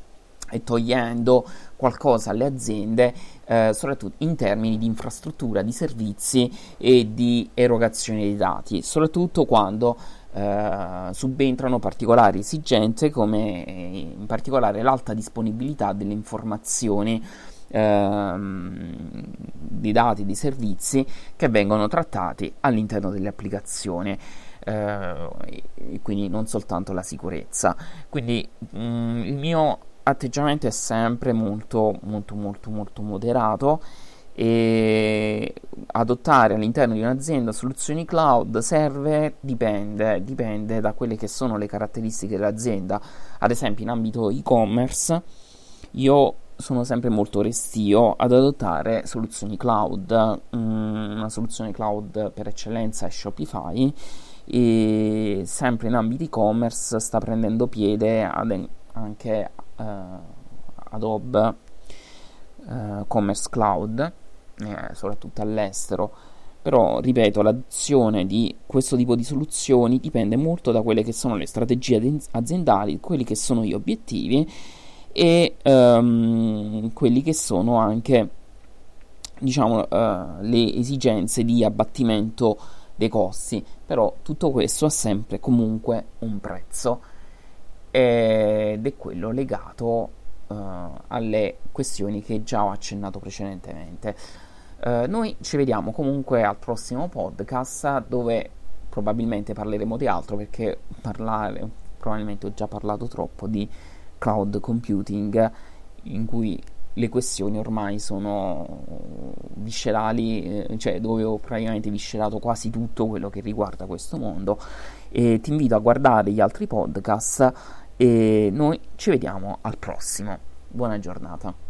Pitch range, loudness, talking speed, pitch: 105-120 Hz, -23 LUFS, 115 wpm, 110 Hz